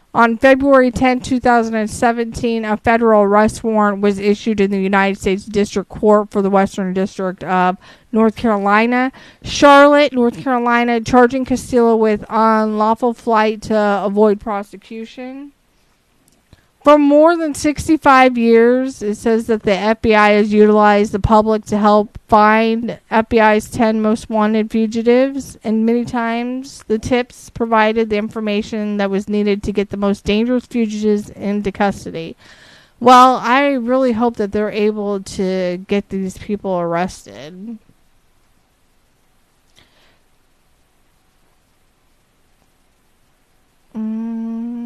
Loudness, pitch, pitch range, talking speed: -15 LUFS, 220 Hz, 205-240 Hz, 120 wpm